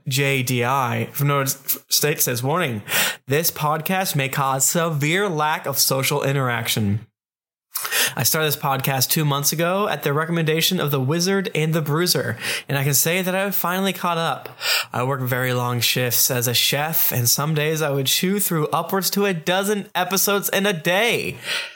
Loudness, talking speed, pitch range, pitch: -20 LUFS, 180 wpm, 135-175 Hz, 150 Hz